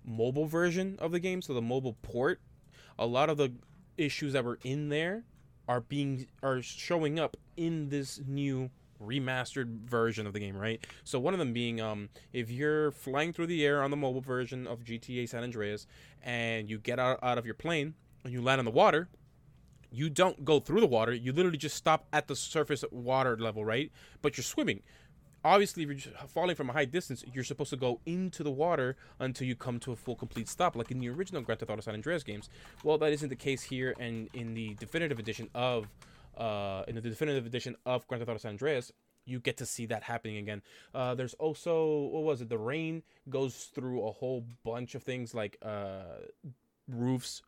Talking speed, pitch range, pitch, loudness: 210 wpm, 115-150 Hz, 130 Hz, -34 LUFS